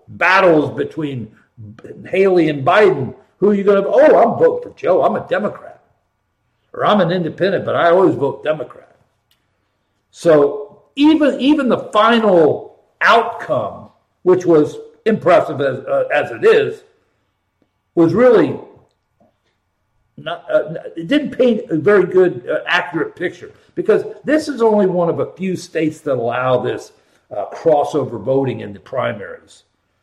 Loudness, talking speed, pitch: -15 LUFS, 145 wpm, 175 Hz